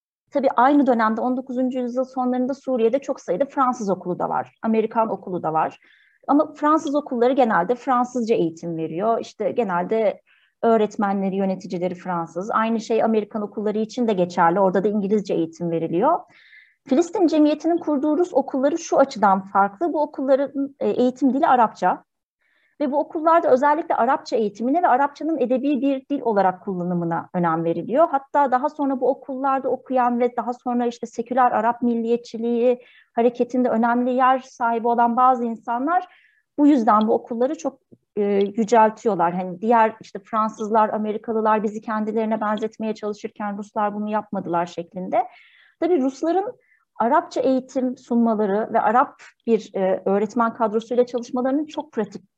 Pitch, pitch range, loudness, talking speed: 235 Hz, 210-270 Hz, -21 LUFS, 140 wpm